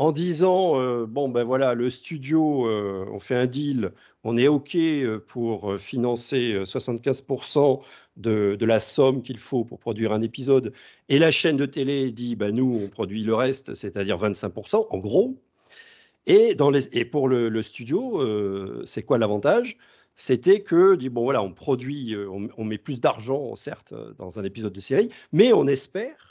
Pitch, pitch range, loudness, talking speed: 130 Hz, 110-145 Hz, -23 LUFS, 180 wpm